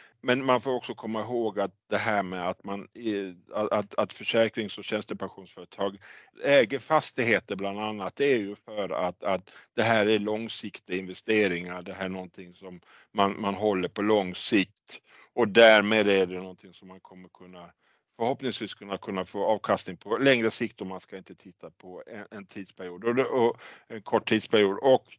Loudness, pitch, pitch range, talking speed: -27 LUFS, 100 Hz, 95-110 Hz, 180 wpm